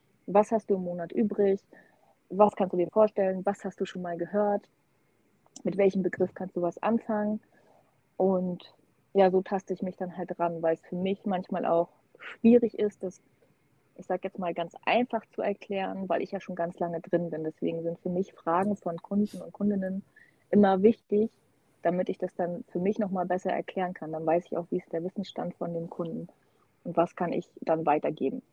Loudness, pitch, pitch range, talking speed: -29 LUFS, 185 Hz, 170-200 Hz, 200 wpm